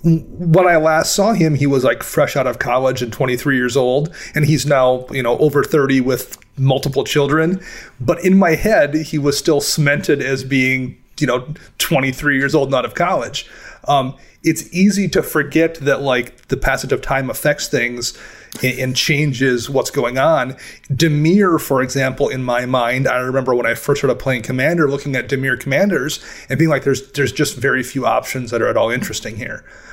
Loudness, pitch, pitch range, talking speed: -16 LUFS, 140 Hz, 130-155 Hz, 195 wpm